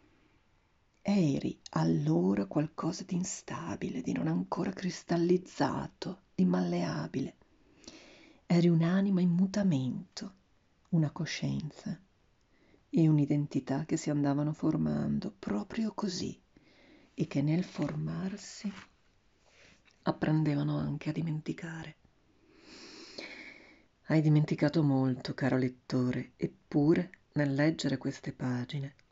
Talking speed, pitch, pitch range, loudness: 90 wpm, 155 Hz, 130-180 Hz, -32 LUFS